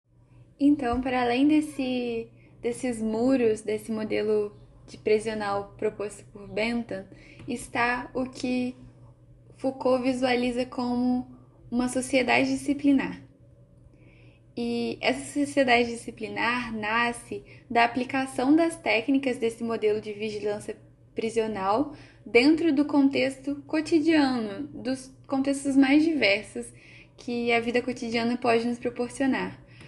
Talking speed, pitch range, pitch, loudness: 100 wpm, 215-265 Hz, 240 Hz, -26 LUFS